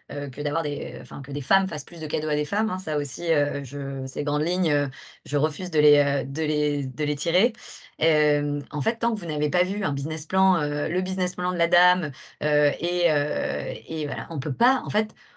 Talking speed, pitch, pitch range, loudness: 245 wpm, 150 Hz, 145-180 Hz, -25 LUFS